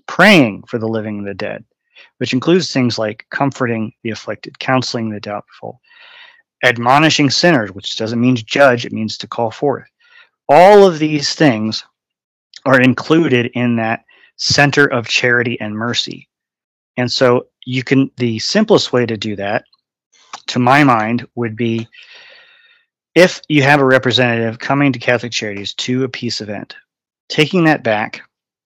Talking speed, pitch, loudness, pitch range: 155 wpm, 125 Hz, -14 LUFS, 115-150 Hz